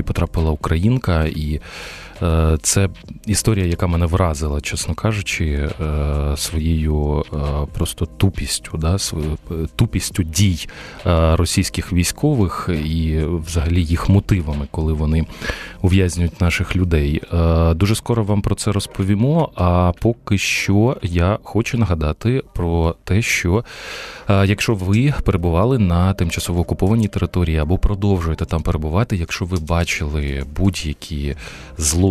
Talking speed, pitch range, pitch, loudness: 110 wpm, 80-100 Hz, 85 Hz, -19 LUFS